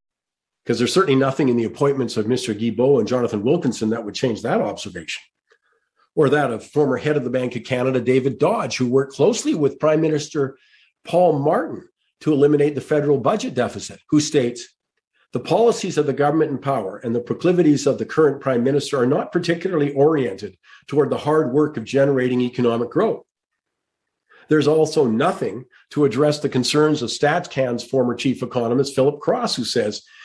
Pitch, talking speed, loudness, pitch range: 140 Hz, 175 wpm, -20 LUFS, 125-150 Hz